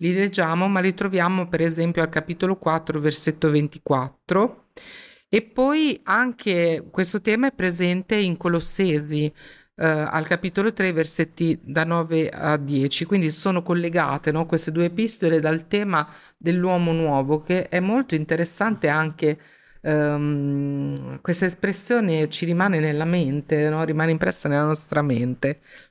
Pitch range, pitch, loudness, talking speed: 155-185 Hz, 165 Hz, -22 LUFS, 135 wpm